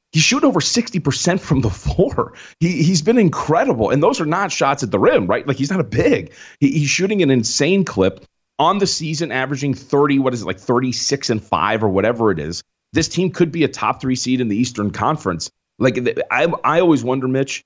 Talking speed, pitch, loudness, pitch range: 225 wpm, 140 Hz, -17 LUFS, 120-170 Hz